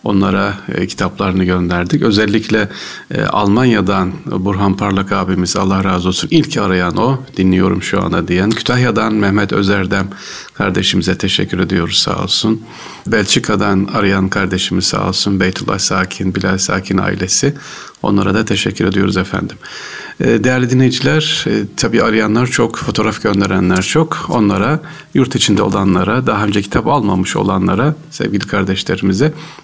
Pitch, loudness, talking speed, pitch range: 100 Hz, -14 LUFS, 120 wpm, 95-115 Hz